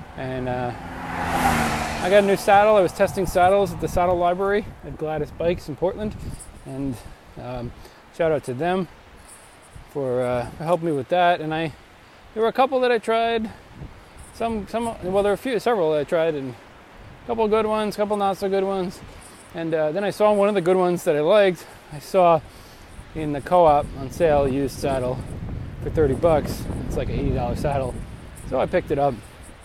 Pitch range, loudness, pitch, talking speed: 130-195 Hz, -22 LUFS, 165 Hz, 200 wpm